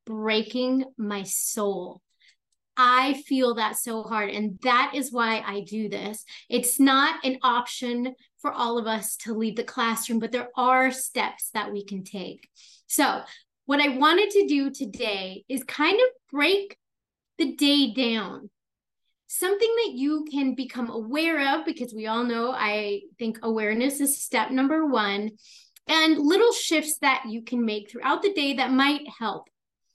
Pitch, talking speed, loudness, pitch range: 250 Hz, 160 wpm, -24 LUFS, 220-285 Hz